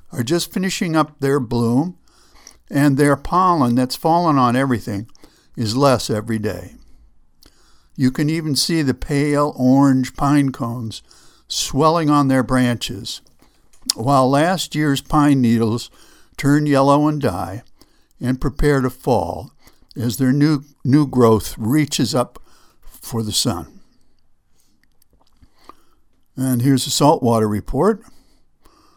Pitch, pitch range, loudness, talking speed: 135 Hz, 120-150 Hz, -18 LUFS, 120 wpm